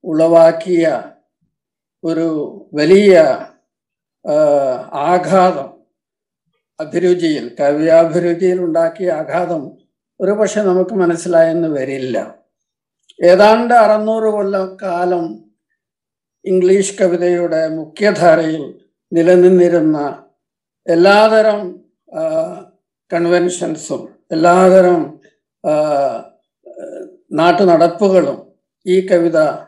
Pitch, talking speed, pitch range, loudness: 180 Hz, 55 wpm, 165-195 Hz, -13 LUFS